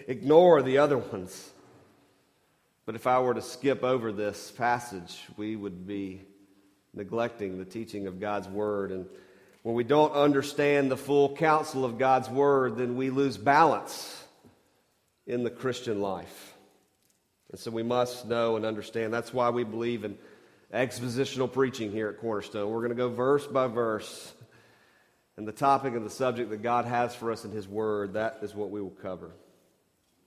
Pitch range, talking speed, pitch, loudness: 105-130 Hz, 170 wpm, 115 Hz, -28 LUFS